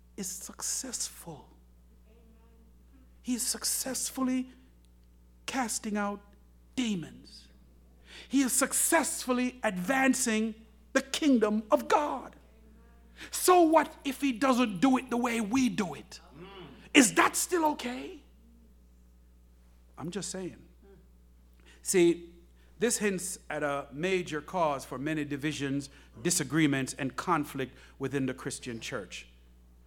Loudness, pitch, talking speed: -29 LUFS, 155 Hz, 105 wpm